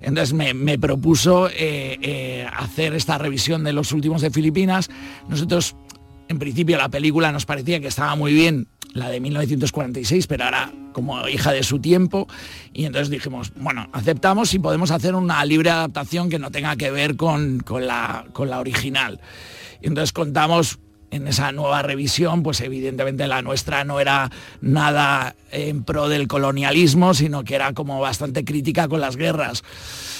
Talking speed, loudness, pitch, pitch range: 165 wpm, -20 LUFS, 145 Hz, 135-160 Hz